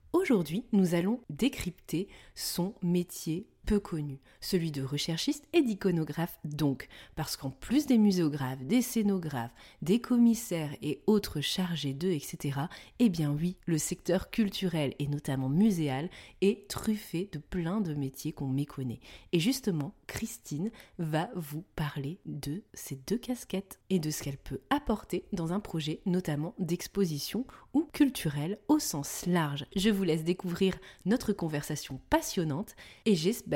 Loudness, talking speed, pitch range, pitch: -32 LUFS, 145 wpm, 150-210 Hz, 175 Hz